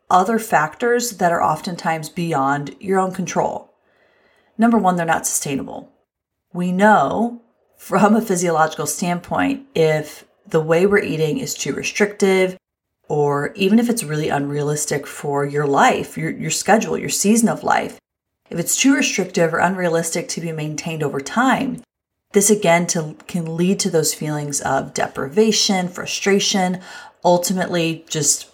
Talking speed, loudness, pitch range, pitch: 140 wpm, -18 LUFS, 160-205 Hz, 175 Hz